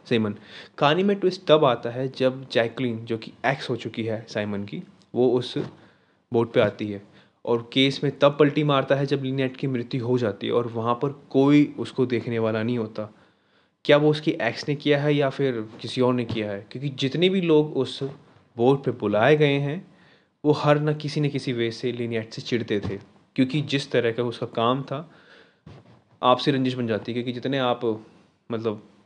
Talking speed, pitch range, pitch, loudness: 200 wpm, 115-140 Hz, 125 Hz, -24 LUFS